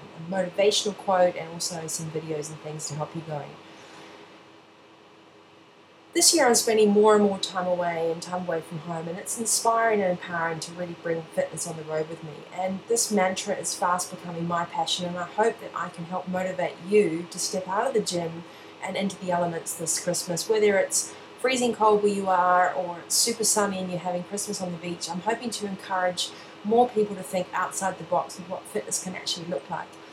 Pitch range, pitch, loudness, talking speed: 165-200 Hz, 180 Hz, -26 LUFS, 210 wpm